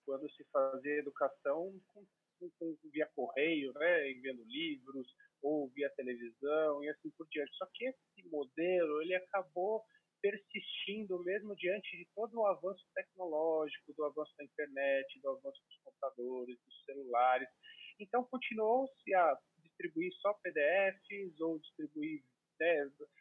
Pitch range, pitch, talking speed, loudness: 145-210 Hz, 175 Hz, 130 wpm, -38 LUFS